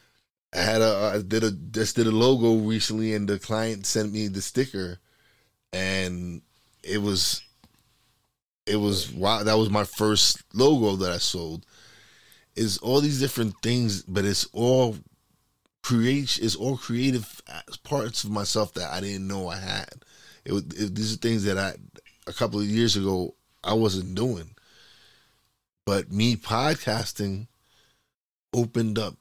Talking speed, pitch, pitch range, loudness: 150 wpm, 110 Hz, 100-115 Hz, -25 LUFS